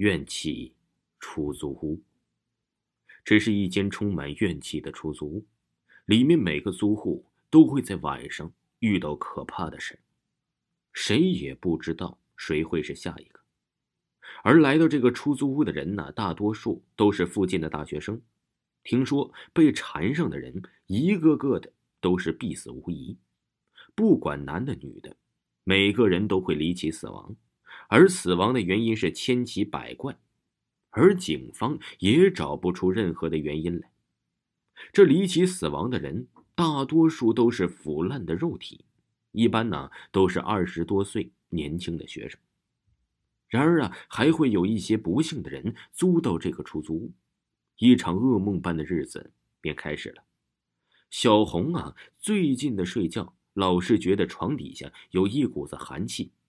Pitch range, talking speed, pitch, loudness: 85-120 Hz, 220 characters per minute, 100 Hz, -25 LUFS